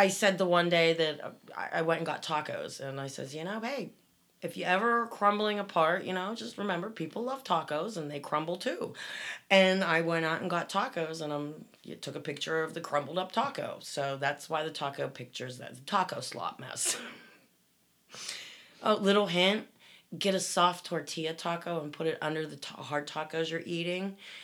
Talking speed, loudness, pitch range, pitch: 195 wpm, -31 LUFS, 160-195 Hz, 170 Hz